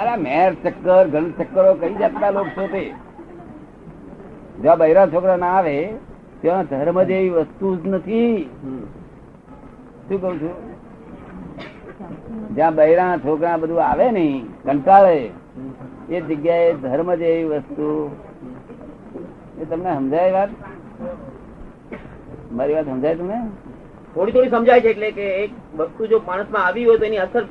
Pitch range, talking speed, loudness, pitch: 160-205 Hz, 85 wpm, -18 LUFS, 185 Hz